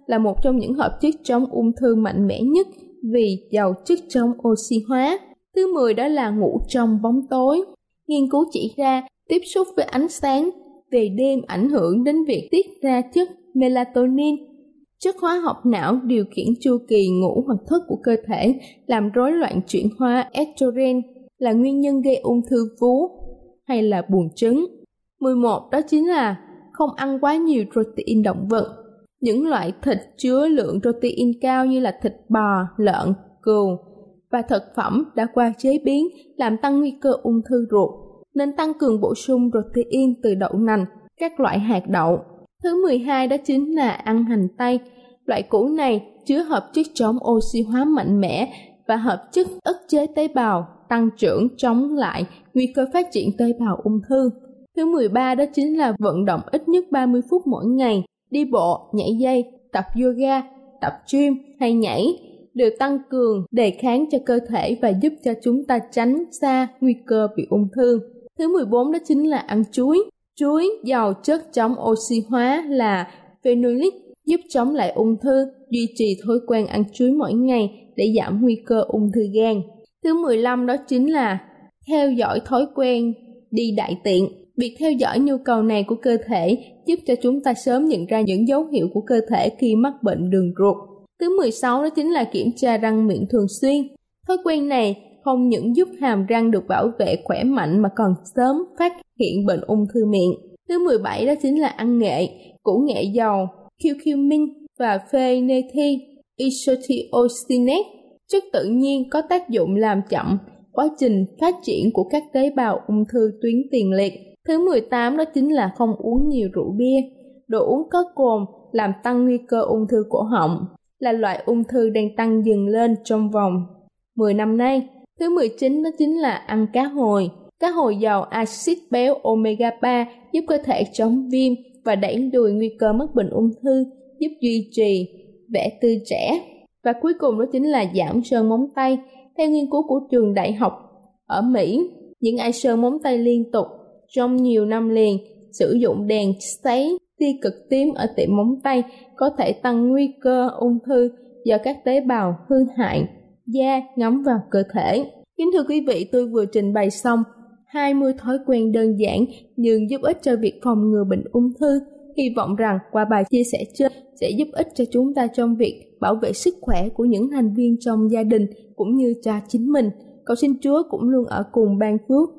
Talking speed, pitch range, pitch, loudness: 190 wpm, 220-275 Hz, 245 Hz, -20 LUFS